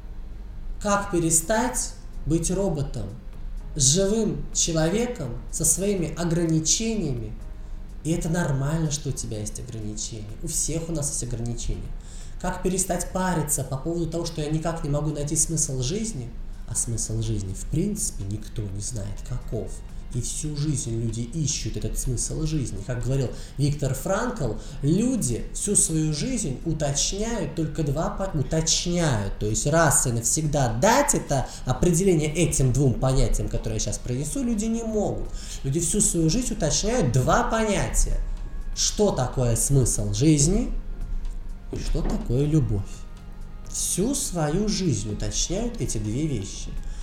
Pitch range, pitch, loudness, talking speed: 115-170 Hz, 145 Hz, -25 LUFS, 135 wpm